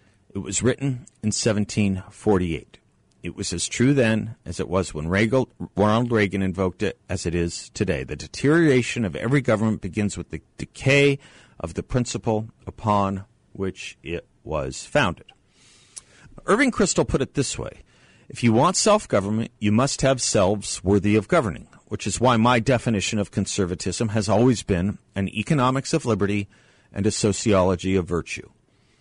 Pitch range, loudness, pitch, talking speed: 95-125 Hz, -22 LUFS, 105 Hz, 155 wpm